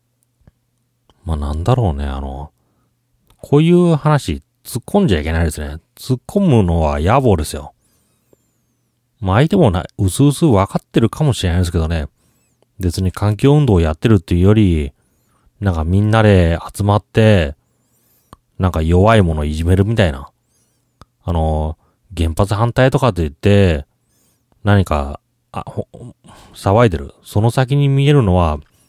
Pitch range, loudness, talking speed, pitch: 80-120 Hz, -15 LUFS, 285 characters per minute, 100 Hz